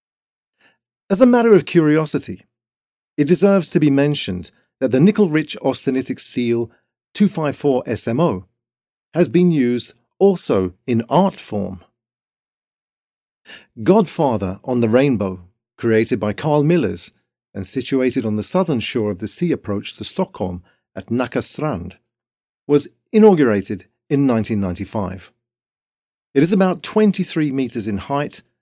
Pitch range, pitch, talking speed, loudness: 105-155 Hz, 125 Hz, 120 wpm, -18 LUFS